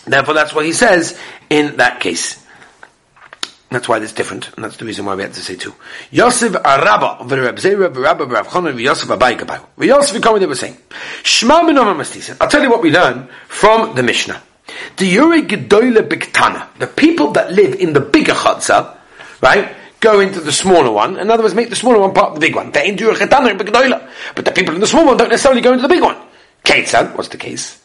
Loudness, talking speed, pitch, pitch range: -12 LUFS, 200 wpm, 215 Hz, 180-265 Hz